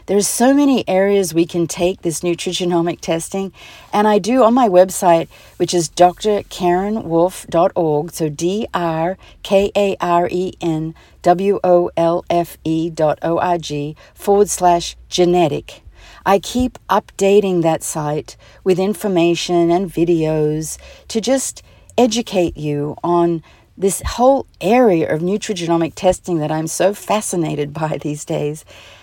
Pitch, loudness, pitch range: 175 Hz, -17 LUFS, 165-195 Hz